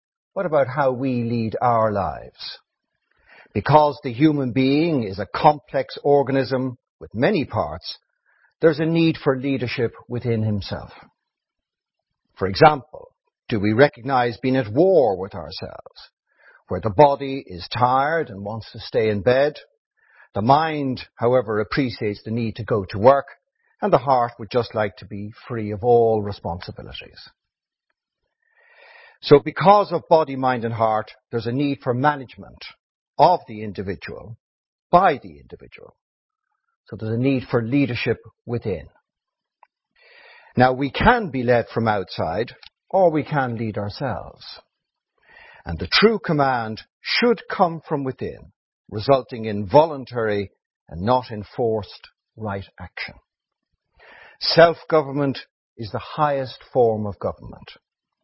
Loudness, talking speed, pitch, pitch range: -21 LUFS, 130 wpm, 125 Hz, 110-145 Hz